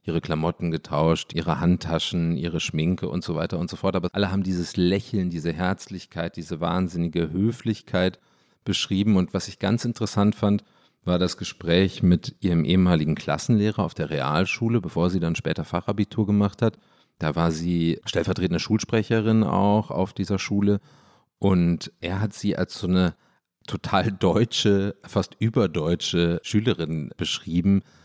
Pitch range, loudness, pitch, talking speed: 85-105 Hz, -24 LUFS, 95 Hz, 150 wpm